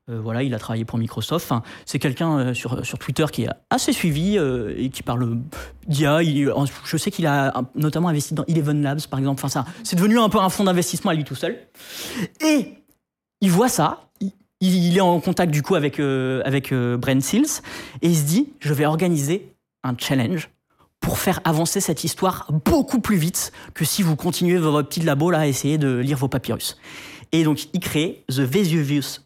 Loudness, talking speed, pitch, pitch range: -21 LUFS, 210 wpm, 155 Hz, 135-180 Hz